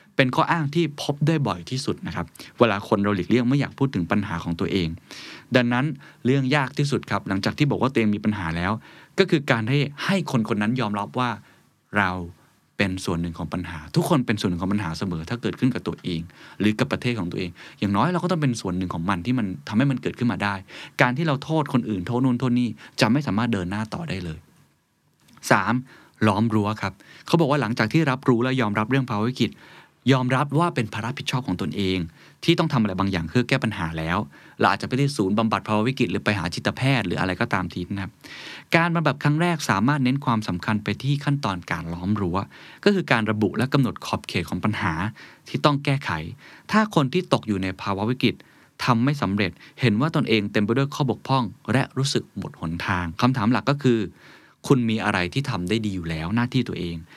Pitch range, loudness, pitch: 100-135 Hz, -23 LUFS, 115 Hz